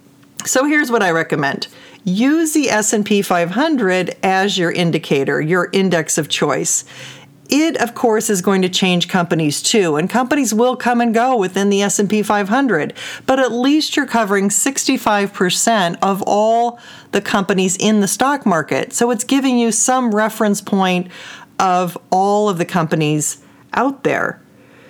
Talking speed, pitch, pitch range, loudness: 150 wpm, 210 Hz, 185-245 Hz, -16 LUFS